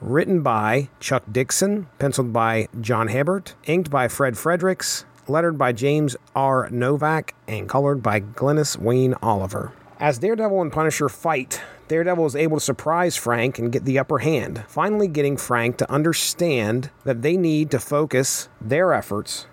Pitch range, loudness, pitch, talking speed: 125-155 Hz, -21 LUFS, 140 Hz, 155 wpm